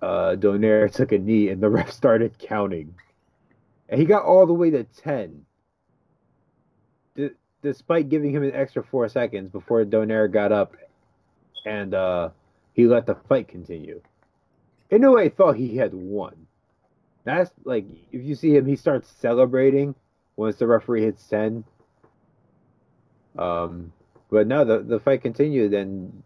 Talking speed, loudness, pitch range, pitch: 150 wpm, -21 LUFS, 100-135 Hz, 110 Hz